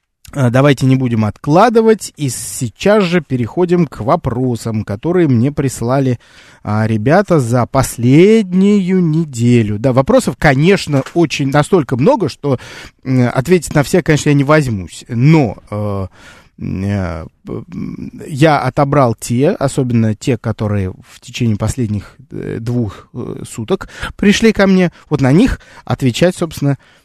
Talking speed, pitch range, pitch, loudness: 125 wpm, 115-165 Hz, 135 Hz, -13 LUFS